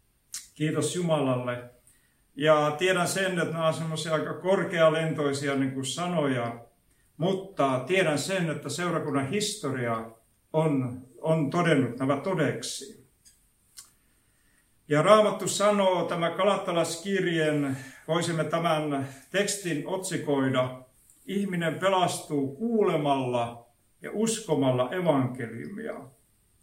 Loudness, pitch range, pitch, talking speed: -27 LUFS, 130-175 Hz, 155 Hz, 90 wpm